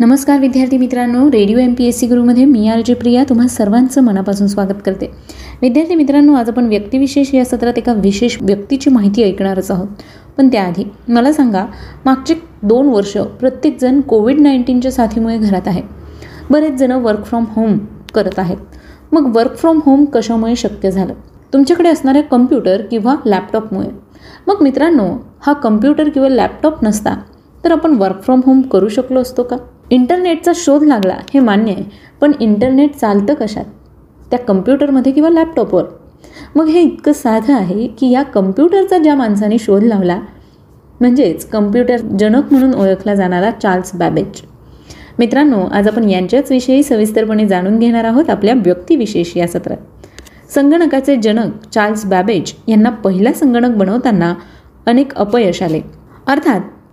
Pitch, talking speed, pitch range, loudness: 245 Hz, 145 wpm, 210-275 Hz, -12 LUFS